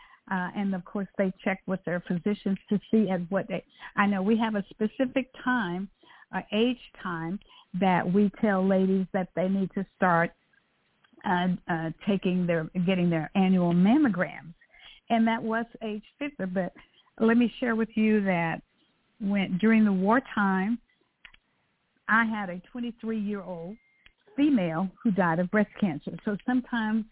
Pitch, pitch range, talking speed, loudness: 200 Hz, 185-225 Hz, 160 wpm, -27 LUFS